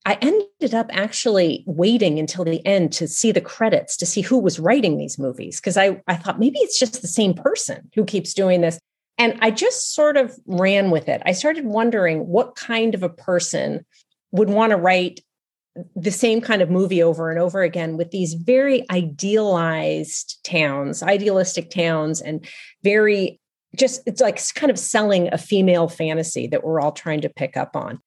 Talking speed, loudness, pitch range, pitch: 190 wpm, -19 LUFS, 170-225 Hz, 190 Hz